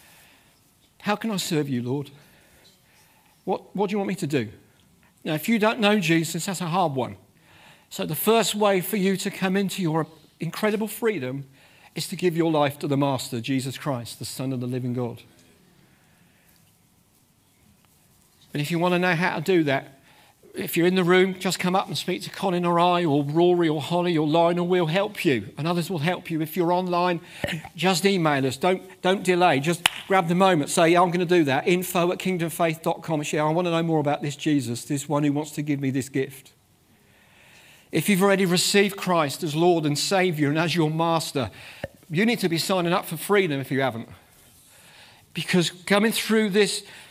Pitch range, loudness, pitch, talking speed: 145-185 Hz, -23 LUFS, 170 Hz, 205 wpm